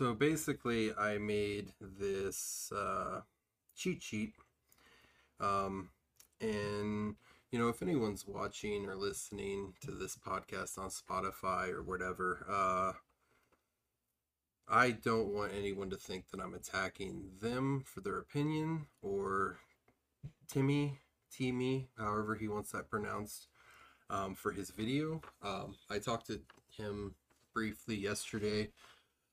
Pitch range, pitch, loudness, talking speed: 100-125 Hz, 105 Hz, -39 LUFS, 115 wpm